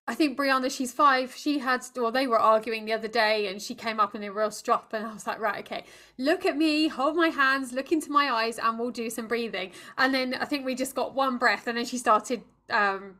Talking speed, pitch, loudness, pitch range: 260 wpm, 245 Hz, -26 LUFS, 225-270 Hz